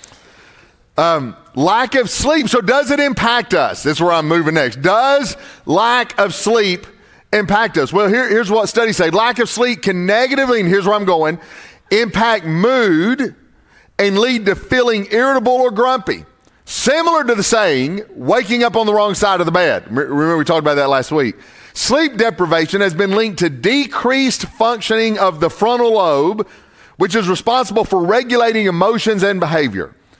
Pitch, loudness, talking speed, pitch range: 220 Hz, -14 LUFS, 170 wpm, 185-240 Hz